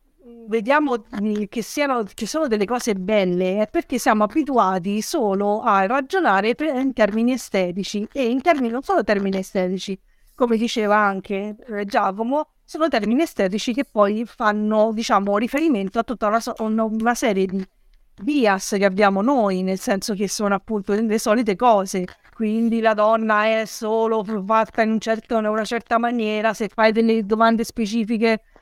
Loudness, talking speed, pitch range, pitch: -20 LUFS, 150 wpm, 205-235 Hz, 220 Hz